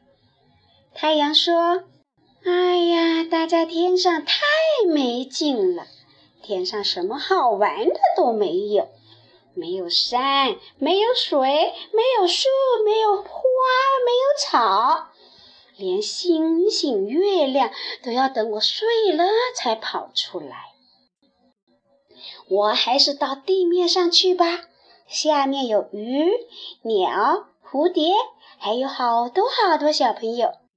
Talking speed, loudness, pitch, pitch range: 150 characters per minute, -20 LUFS, 335 Hz, 275-380 Hz